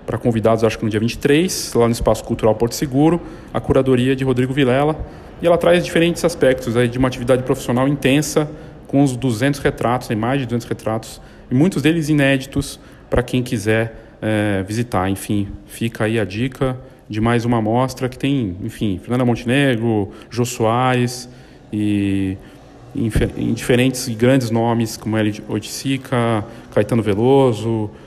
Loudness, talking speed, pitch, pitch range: -18 LUFS, 155 wpm, 125 Hz, 115-135 Hz